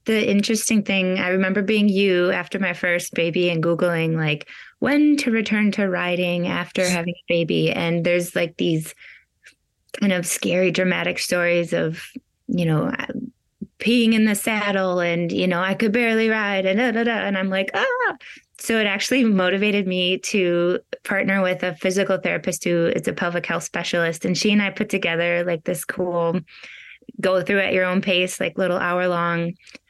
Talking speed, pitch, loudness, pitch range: 180 wpm, 185 Hz, -21 LUFS, 175-210 Hz